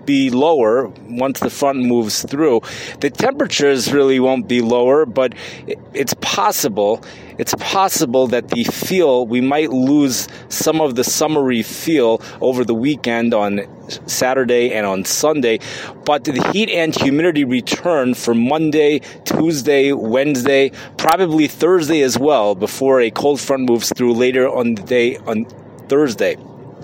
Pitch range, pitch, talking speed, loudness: 120-155 Hz, 135 Hz, 140 wpm, -16 LUFS